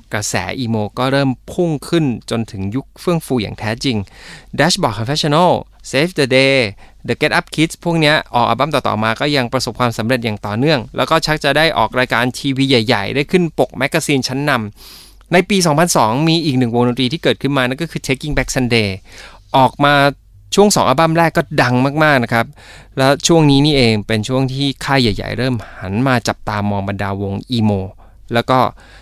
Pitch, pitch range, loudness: 130 Hz, 110-145 Hz, -15 LUFS